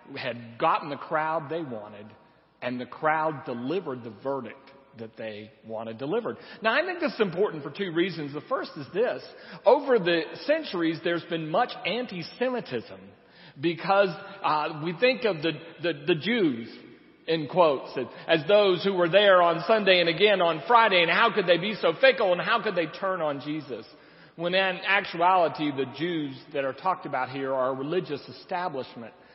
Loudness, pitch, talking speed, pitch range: -26 LUFS, 170 Hz, 175 wpm, 140-195 Hz